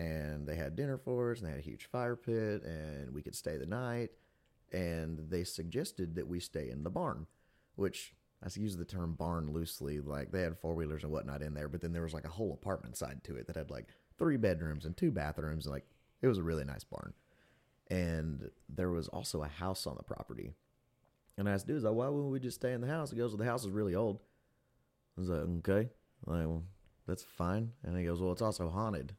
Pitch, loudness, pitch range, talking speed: 85 Hz, -39 LUFS, 80-105 Hz, 240 wpm